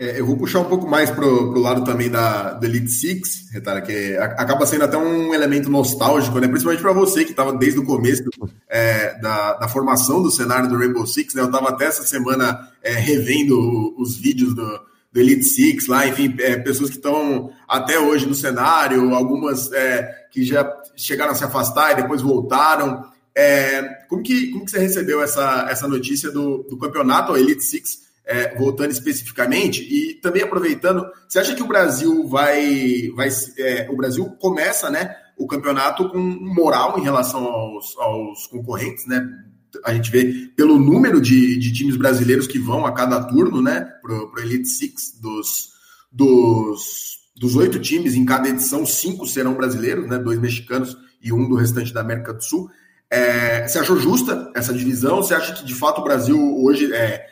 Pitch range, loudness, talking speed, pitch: 125-150 Hz, -18 LUFS, 180 wpm, 130 Hz